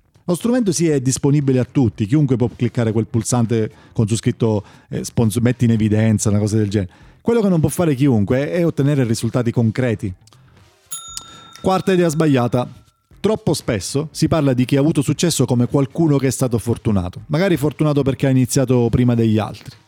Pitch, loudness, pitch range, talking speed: 130 Hz, -18 LUFS, 115-150 Hz, 185 wpm